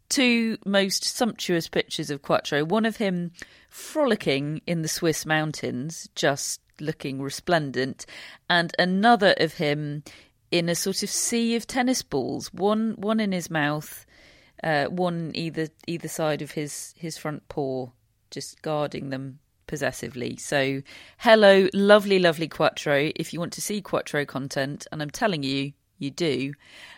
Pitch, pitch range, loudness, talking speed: 160 Hz, 145-195 Hz, -25 LUFS, 145 wpm